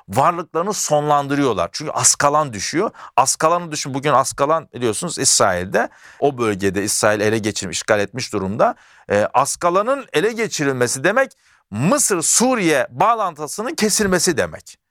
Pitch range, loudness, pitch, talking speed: 110-180 Hz, -18 LUFS, 145 Hz, 115 wpm